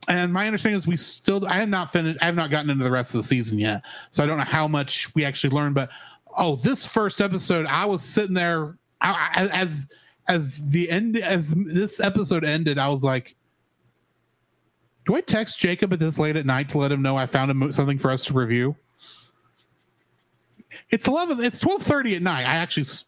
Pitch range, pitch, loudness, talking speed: 140-190 Hz, 160 Hz, -23 LUFS, 205 wpm